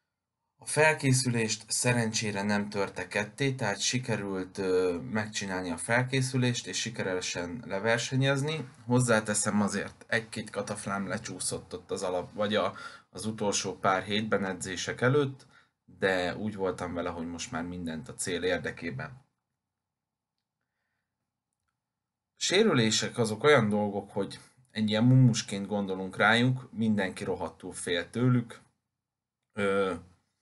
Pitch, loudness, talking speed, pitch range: 110 Hz, -29 LUFS, 115 wpm, 95-120 Hz